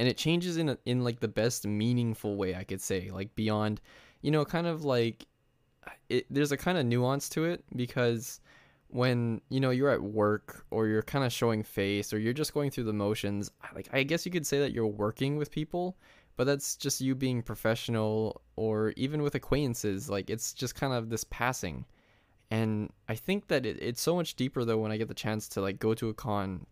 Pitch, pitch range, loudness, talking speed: 120 Hz, 105-140 Hz, -31 LUFS, 220 wpm